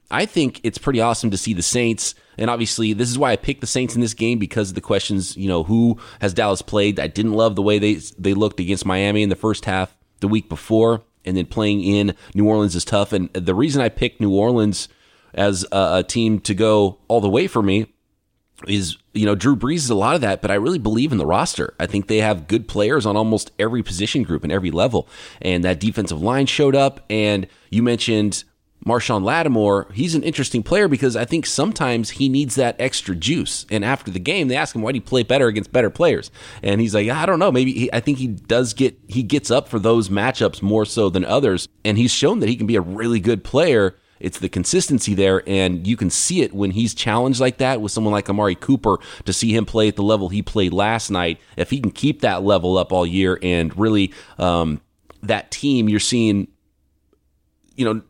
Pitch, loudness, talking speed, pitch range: 105 Hz, -19 LUFS, 235 wpm, 100-120 Hz